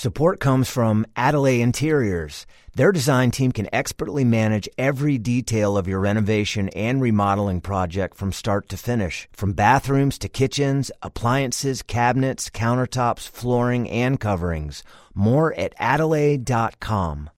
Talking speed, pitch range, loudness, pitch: 125 wpm, 100-135 Hz, -21 LUFS, 120 Hz